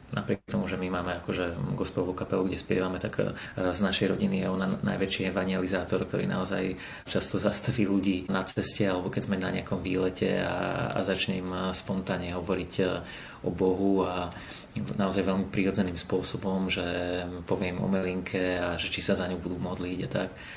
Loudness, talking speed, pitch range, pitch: -30 LUFS, 165 wpm, 90-95 Hz, 95 Hz